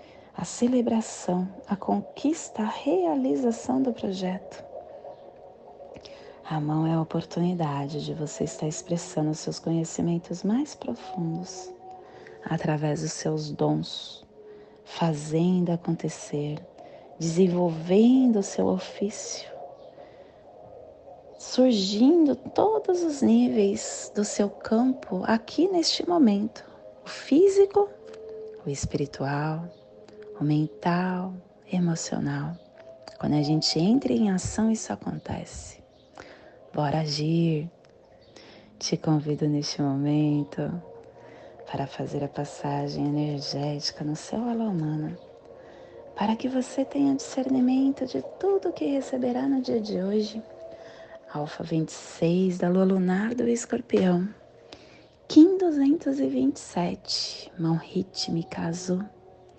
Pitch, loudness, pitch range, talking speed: 185 Hz, -26 LUFS, 155-255 Hz, 100 wpm